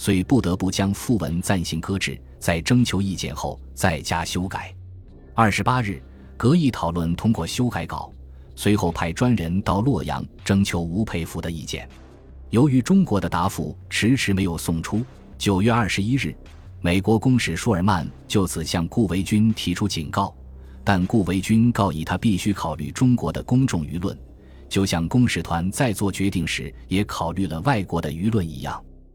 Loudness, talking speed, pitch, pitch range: -22 LUFS, 260 characters per minute, 95 Hz, 80-105 Hz